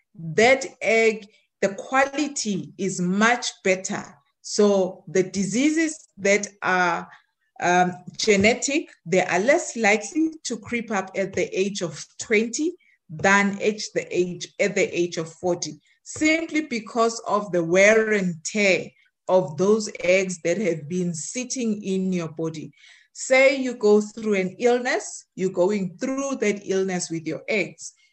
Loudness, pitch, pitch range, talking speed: -23 LUFS, 200 Hz, 180-235 Hz, 140 wpm